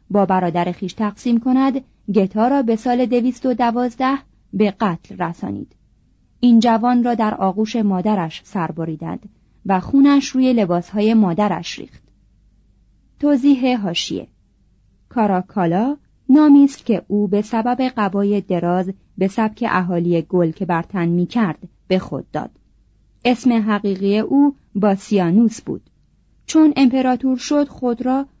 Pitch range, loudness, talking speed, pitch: 185-250 Hz, -18 LUFS, 130 wpm, 215 Hz